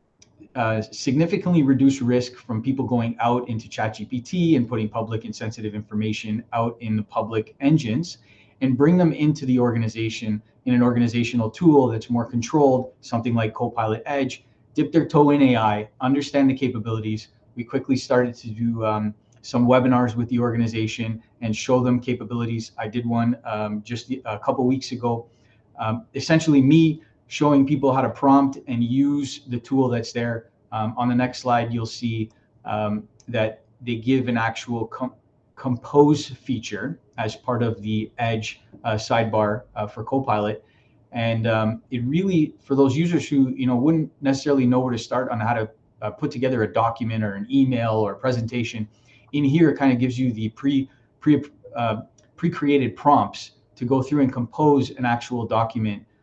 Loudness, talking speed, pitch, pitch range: -22 LUFS, 175 wpm, 120 Hz, 110-135 Hz